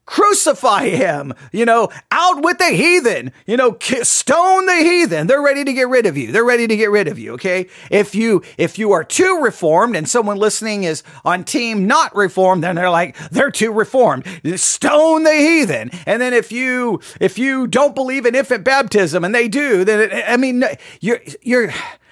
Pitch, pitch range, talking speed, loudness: 240 Hz, 195-280 Hz, 195 wpm, -15 LUFS